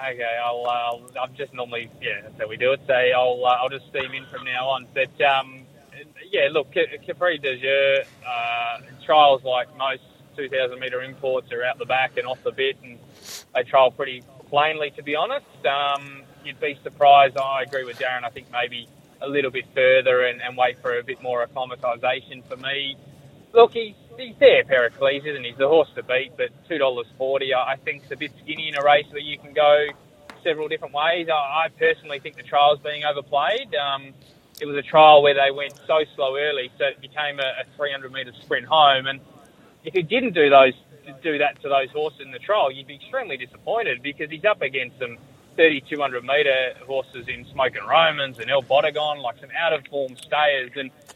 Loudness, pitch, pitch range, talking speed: -21 LUFS, 140 Hz, 130-155 Hz, 210 wpm